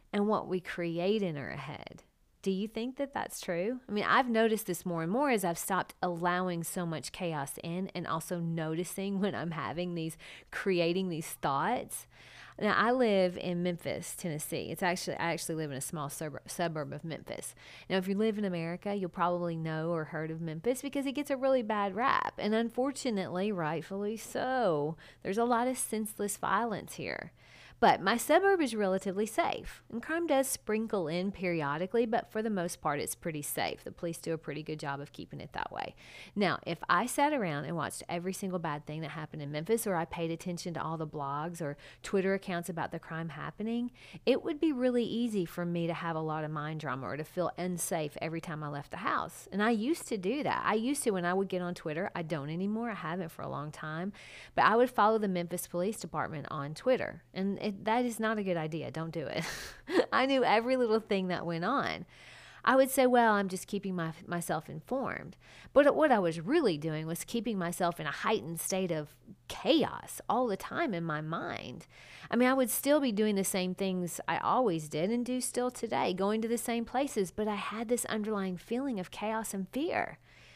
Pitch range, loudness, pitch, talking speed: 165-225 Hz, -33 LUFS, 185 Hz, 215 wpm